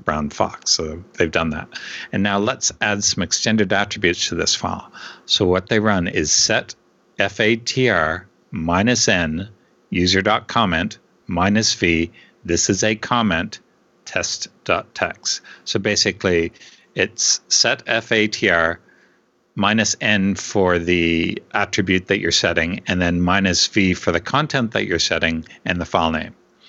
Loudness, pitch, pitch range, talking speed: -18 LUFS, 100 Hz, 85-105 Hz, 135 wpm